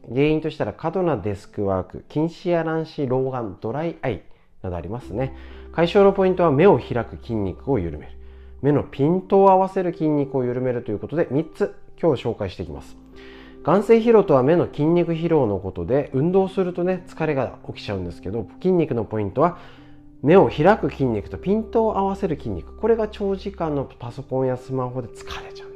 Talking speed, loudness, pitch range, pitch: 385 characters per minute, -21 LUFS, 105-175 Hz, 140 Hz